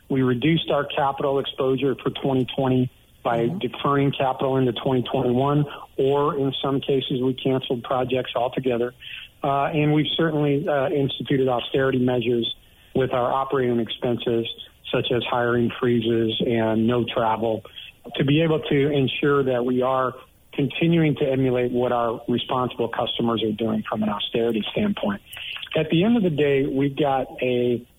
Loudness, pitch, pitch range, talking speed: -23 LUFS, 130 Hz, 120-140 Hz, 150 wpm